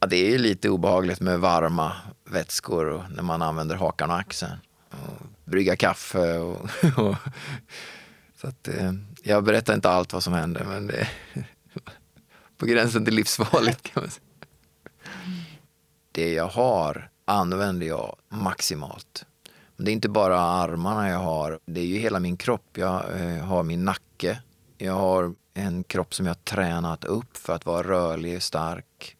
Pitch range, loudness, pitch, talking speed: 85-105 Hz, -25 LUFS, 90 Hz, 160 wpm